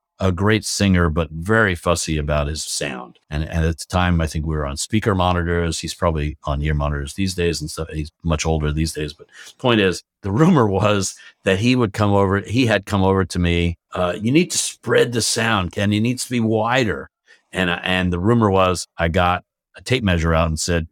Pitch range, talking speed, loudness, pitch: 80-100 Hz, 230 wpm, -19 LUFS, 90 Hz